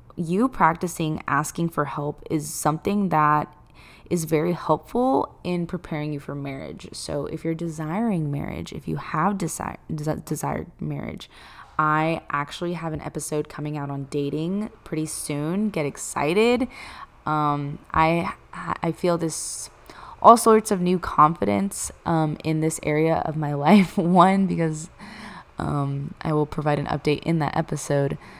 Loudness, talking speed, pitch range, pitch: -24 LUFS, 145 wpm, 150-175 Hz, 155 Hz